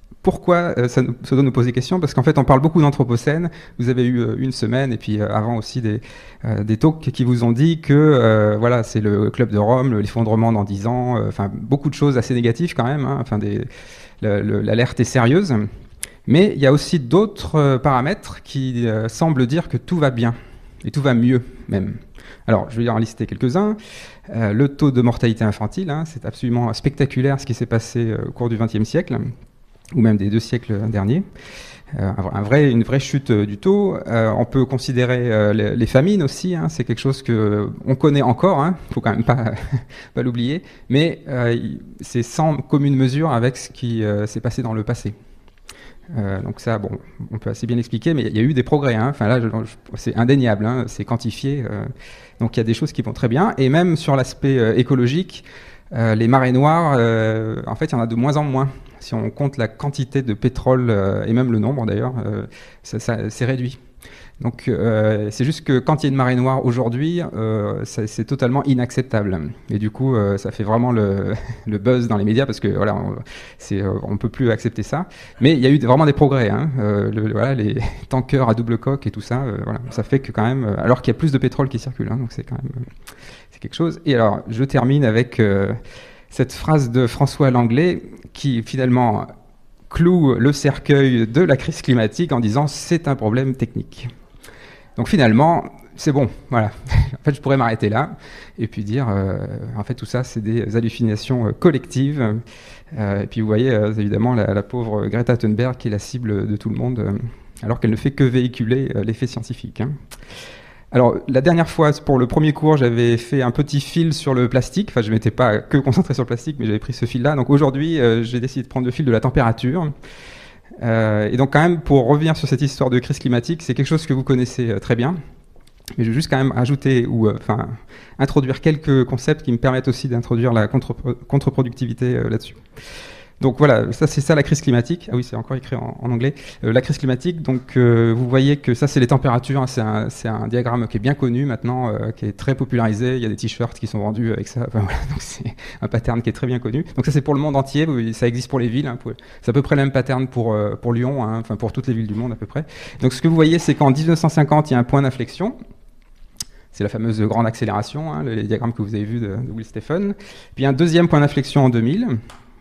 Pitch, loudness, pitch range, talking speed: 125 Hz, -19 LUFS, 115-140 Hz, 235 wpm